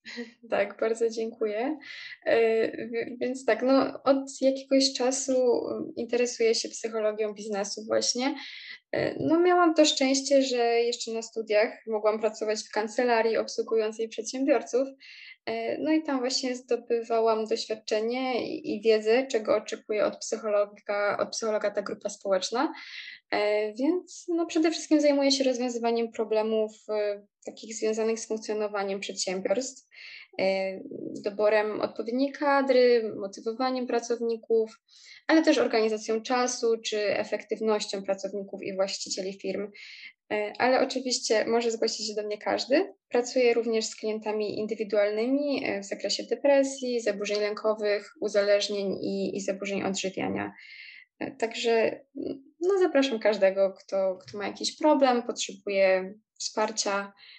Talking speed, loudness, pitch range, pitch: 115 wpm, -27 LUFS, 210-265 Hz, 225 Hz